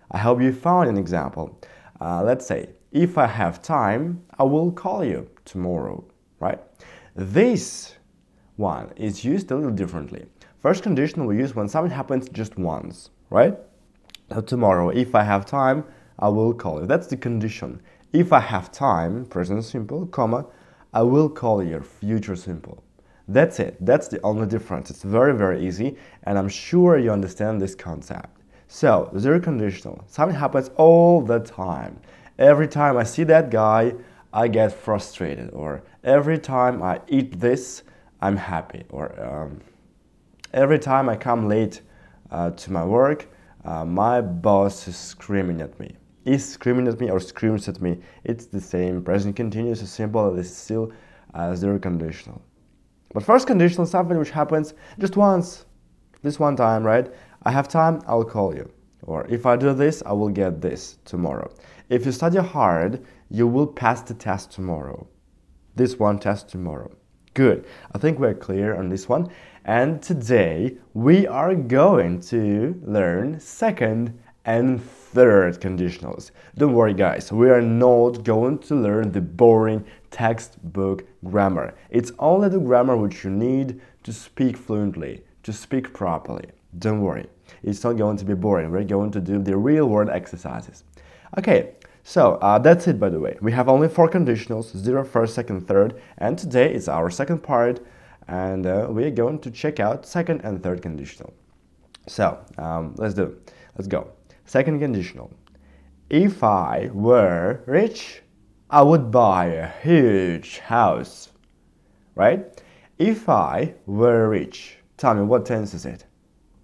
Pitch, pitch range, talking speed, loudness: 110 Hz, 95-130 Hz, 160 wpm, -21 LUFS